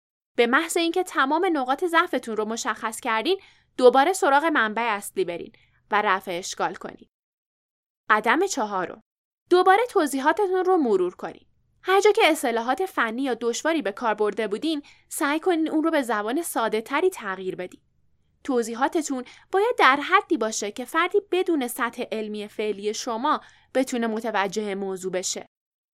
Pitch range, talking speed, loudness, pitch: 220-335 Hz, 145 wpm, -23 LUFS, 260 Hz